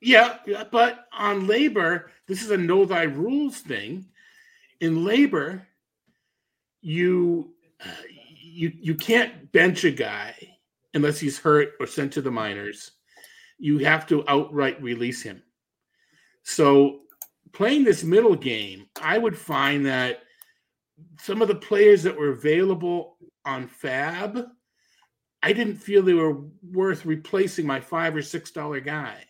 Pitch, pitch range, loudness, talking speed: 165 Hz, 145-205 Hz, -23 LUFS, 135 wpm